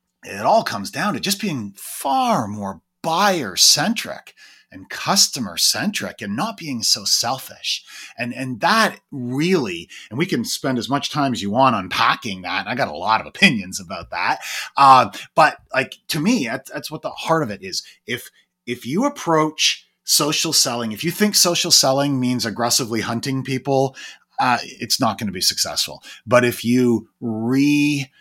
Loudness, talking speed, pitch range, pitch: -19 LUFS, 175 wpm, 120-155 Hz, 135 Hz